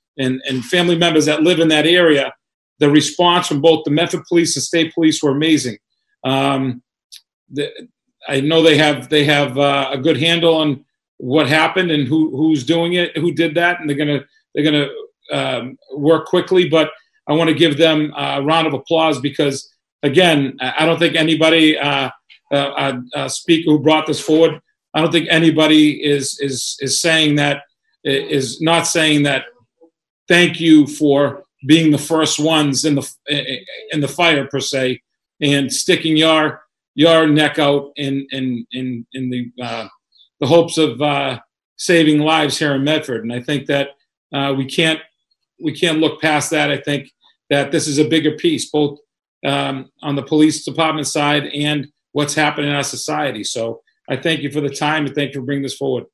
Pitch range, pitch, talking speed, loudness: 140-160 Hz, 150 Hz, 185 wpm, -16 LUFS